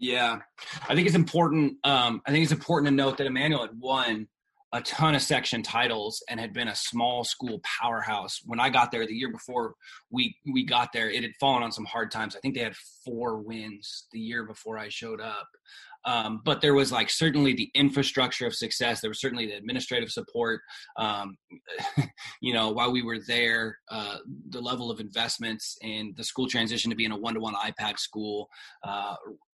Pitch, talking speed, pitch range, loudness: 120 Hz, 195 wpm, 110-140 Hz, -28 LUFS